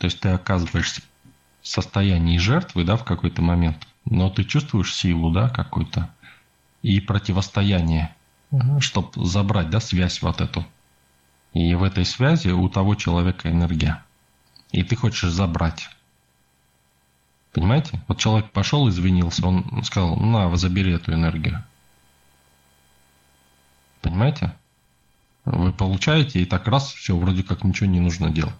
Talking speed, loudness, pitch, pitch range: 130 wpm, -21 LUFS, 90 Hz, 65-100 Hz